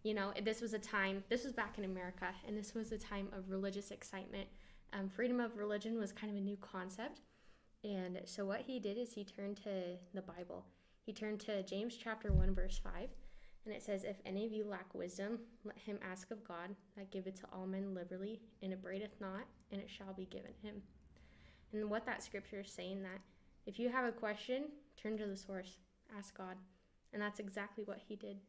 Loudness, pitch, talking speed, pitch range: -45 LUFS, 200 Hz, 215 wpm, 190-215 Hz